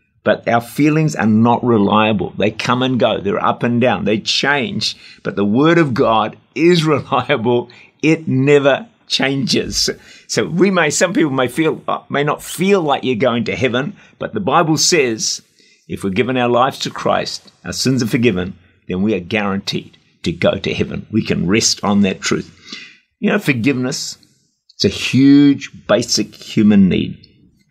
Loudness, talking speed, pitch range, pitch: -16 LUFS, 170 wpm, 110-150 Hz, 130 Hz